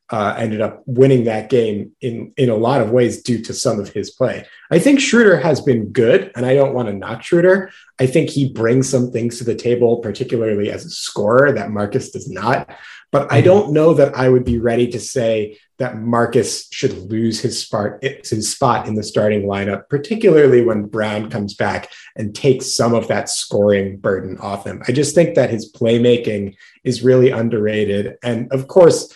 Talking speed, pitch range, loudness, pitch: 195 wpm, 105-130 Hz, -16 LUFS, 120 Hz